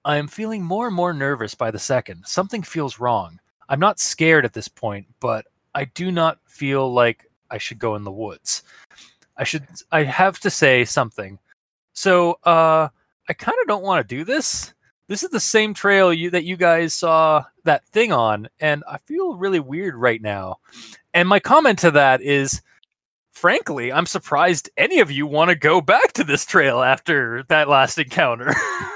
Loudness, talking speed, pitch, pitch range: -19 LUFS, 190 wpm, 155 Hz, 125-180 Hz